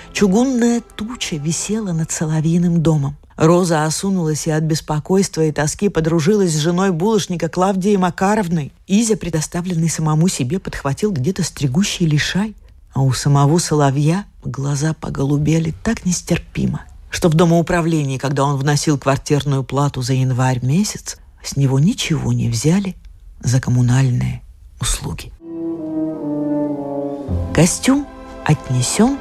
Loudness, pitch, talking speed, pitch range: -17 LUFS, 160 Hz, 115 wpm, 140-180 Hz